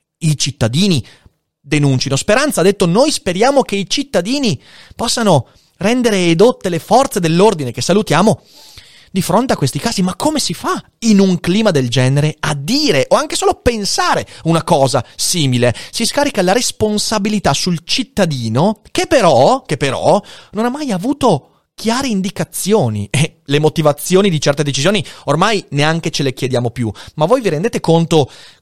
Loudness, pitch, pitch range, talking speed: -14 LUFS, 185 Hz, 145-220 Hz, 160 wpm